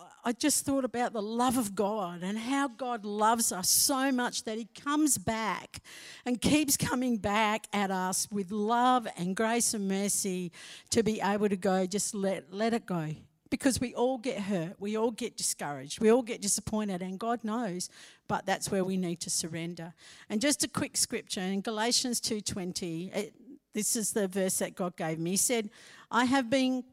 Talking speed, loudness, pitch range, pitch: 190 wpm, -30 LUFS, 190-245 Hz, 215 Hz